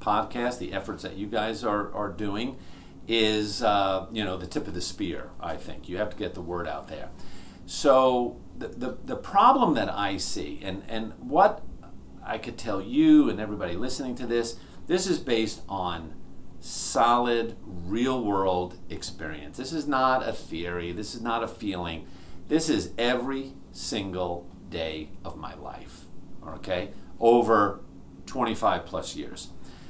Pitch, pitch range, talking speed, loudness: 100 Hz, 90-115 Hz, 160 wpm, -27 LUFS